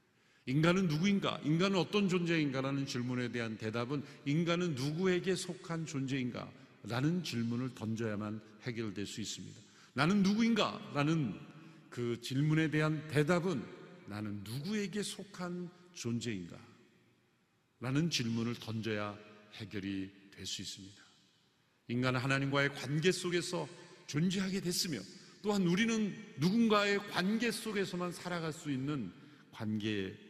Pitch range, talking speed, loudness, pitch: 120-180 Hz, 290 characters per minute, -35 LUFS, 150 Hz